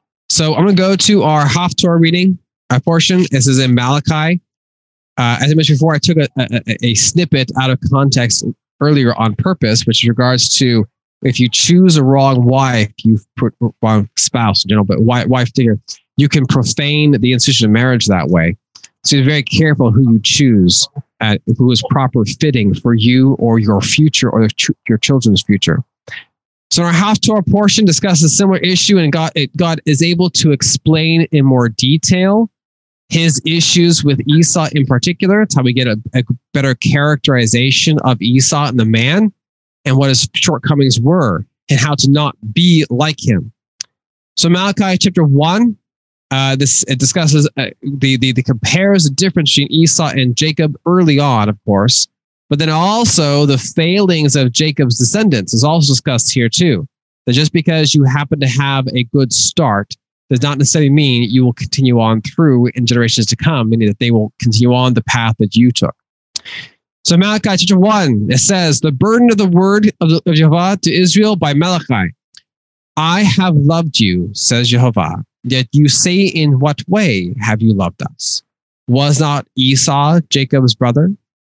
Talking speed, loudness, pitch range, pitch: 180 wpm, -12 LUFS, 125-165 Hz, 140 Hz